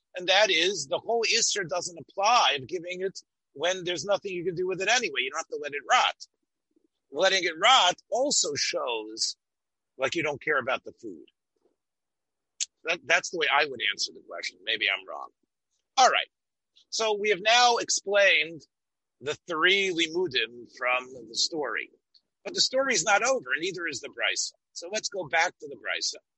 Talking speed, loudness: 185 wpm, -26 LUFS